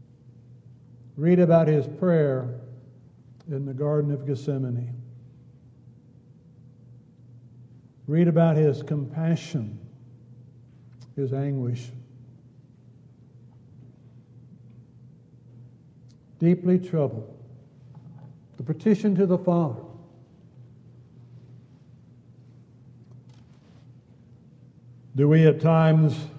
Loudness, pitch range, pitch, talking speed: -23 LUFS, 125-145 Hz, 130 Hz, 60 wpm